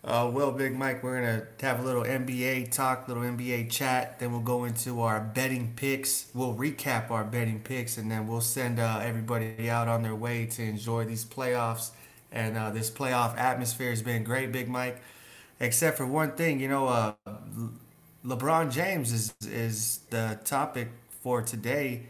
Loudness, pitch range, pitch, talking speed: -30 LUFS, 115-130 Hz, 120 Hz, 180 wpm